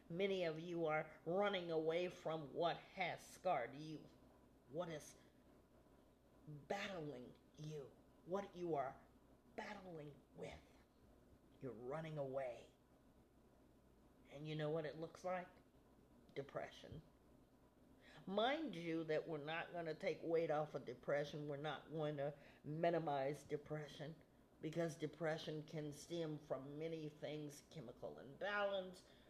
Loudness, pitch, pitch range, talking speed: -47 LUFS, 155 Hz, 150-170 Hz, 120 wpm